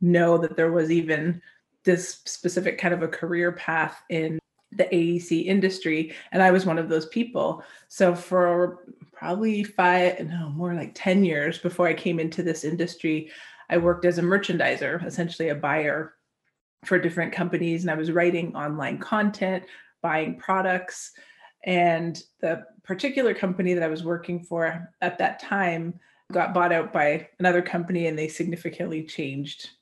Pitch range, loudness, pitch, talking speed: 165-180 Hz, -25 LUFS, 175 Hz, 160 wpm